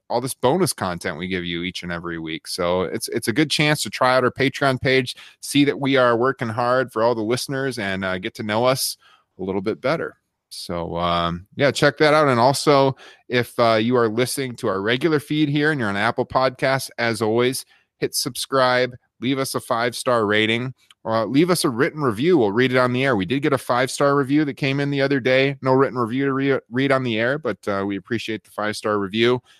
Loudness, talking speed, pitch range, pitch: -20 LUFS, 240 wpm, 110-135 Hz, 125 Hz